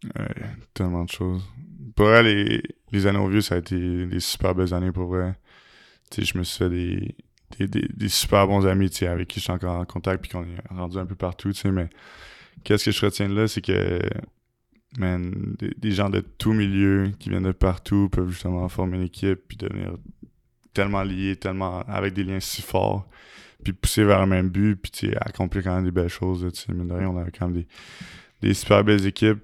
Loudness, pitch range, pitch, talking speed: -24 LUFS, 90-105 Hz, 95 Hz, 215 wpm